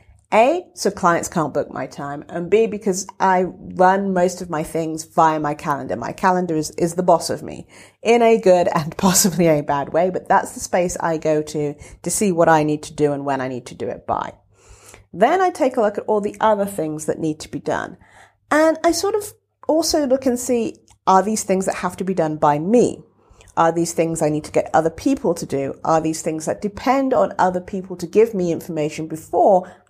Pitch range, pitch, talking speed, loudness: 155-210 Hz, 175 Hz, 230 wpm, -19 LUFS